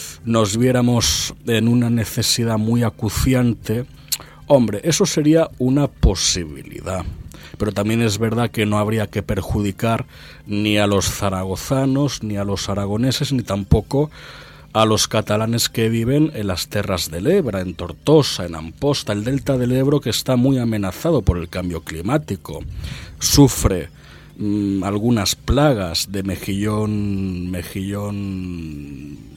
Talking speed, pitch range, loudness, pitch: 130 wpm, 100-125 Hz, -19 LUFS, 110 Hz